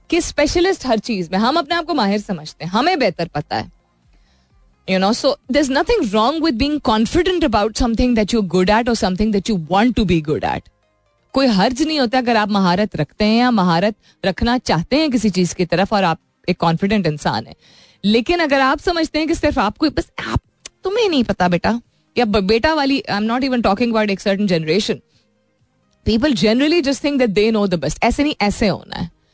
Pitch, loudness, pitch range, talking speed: 220 Hz, -17 LUFS, 185-275 Hz, 210 wpm